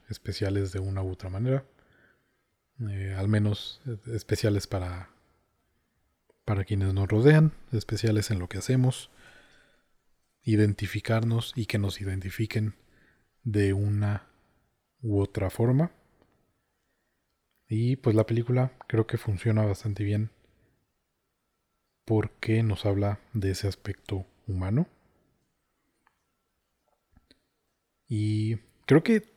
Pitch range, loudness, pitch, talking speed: 100-115 Hz, -28 LUFS, 105 Hz, 100 wpm